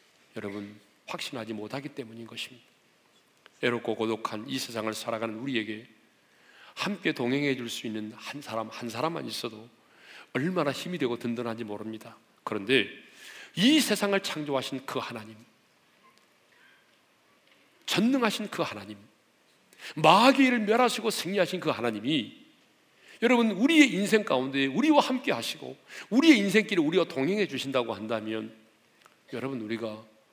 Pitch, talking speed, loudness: 130 Hz, 305 characters per minute, -27 LUFS